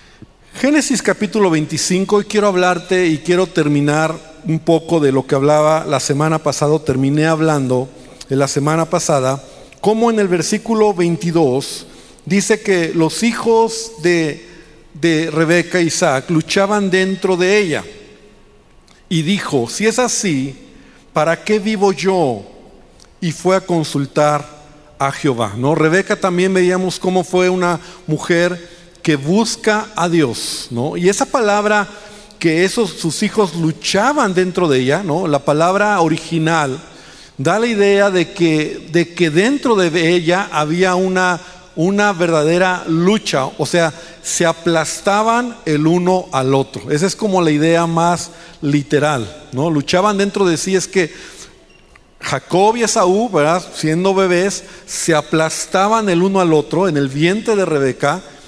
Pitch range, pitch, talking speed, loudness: 155-195 Hz, 175 Hz, 140 wpm, -15 LUFS